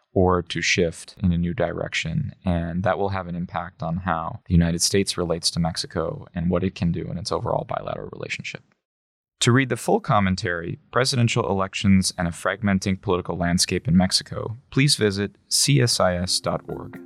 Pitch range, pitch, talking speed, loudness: 85-110 Hz, 95 Hz, 170 wpm, -23 LUFS